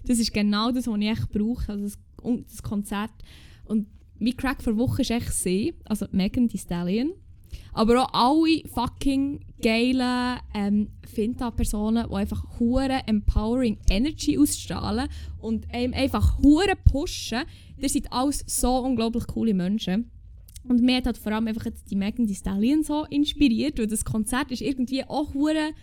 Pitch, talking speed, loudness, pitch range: 235 Hz, 165 wpm, -25 LUFS, 215-265 Hz